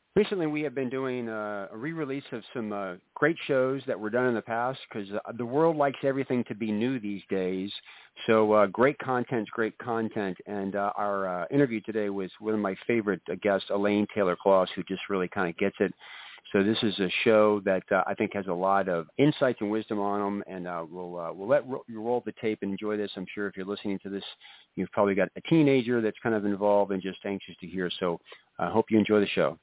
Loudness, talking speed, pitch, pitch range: -28 LUFS, 240 wpm, 105 Hz, 100-120 Hz